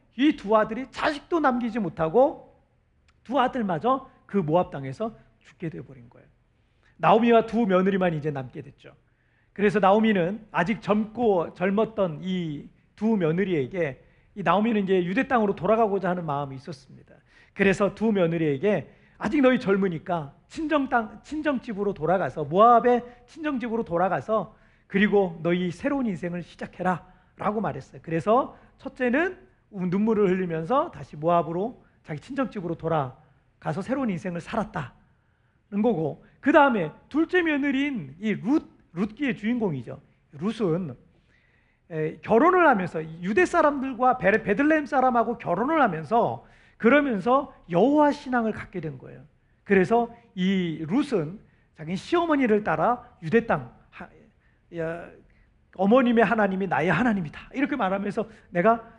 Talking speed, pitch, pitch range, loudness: 315 characters per minute, 205 Hz, 170-240 Hz, -24 LUFS